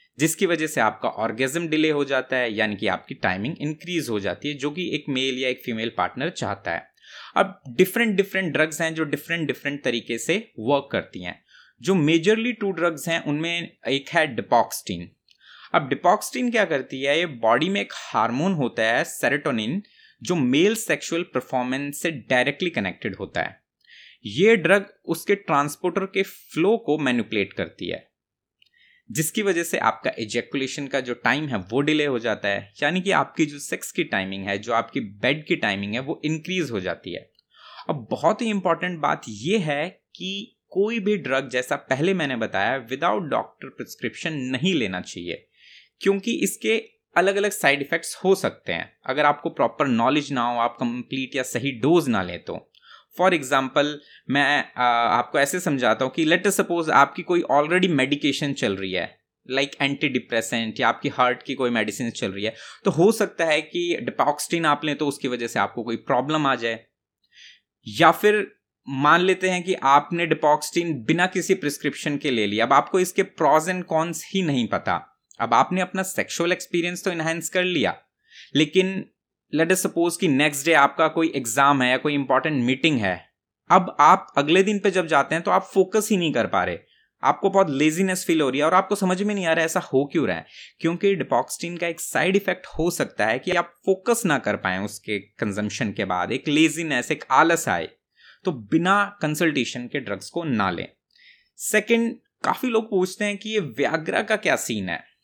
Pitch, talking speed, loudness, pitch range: 155 Hz, 190 wpm, -23 LUFS, 130-185 Hz